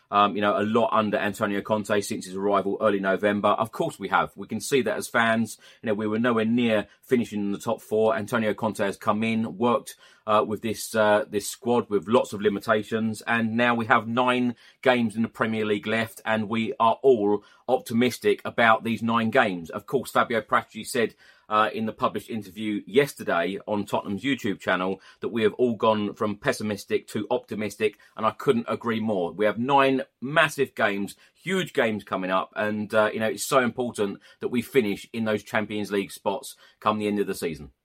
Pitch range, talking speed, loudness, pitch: 105-115 Hz, 205 wpm, -25 LUFS, 110 Hz